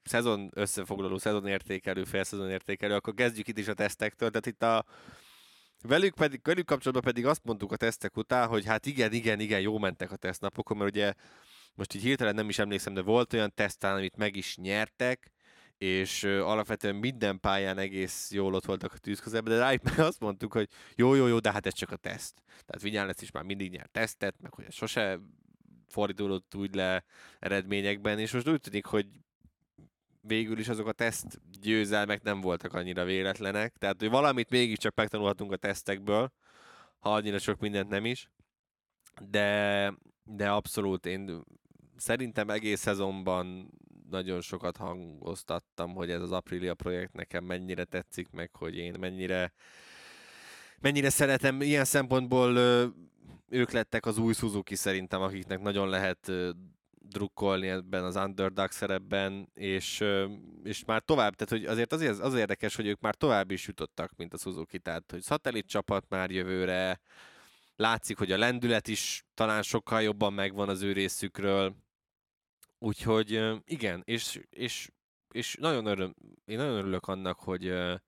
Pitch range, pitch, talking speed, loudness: 95-110 Hz, 100 Hz, 155 wpm, -31 LUFS